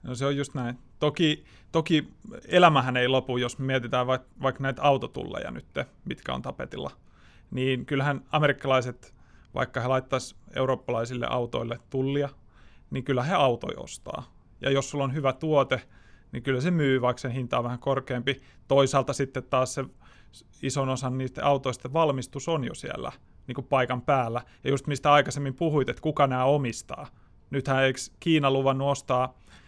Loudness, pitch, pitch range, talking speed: -27 LUFS, 135 Hz, 125-140 Hz, 160 wpm